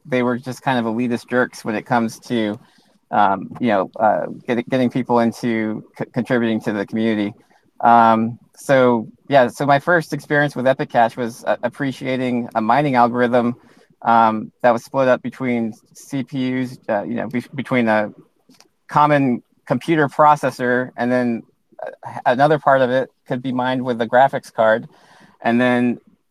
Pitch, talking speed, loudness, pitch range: 125 Hz, 160 wpm, -18 LUFS, 115-130 Hz